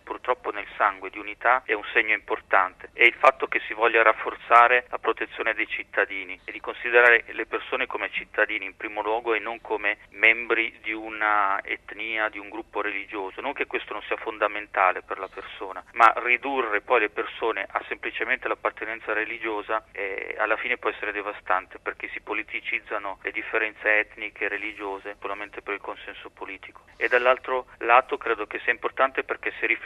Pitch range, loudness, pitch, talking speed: 105-115 Hz, -24 LUFS, 110 Hz, 175 wpm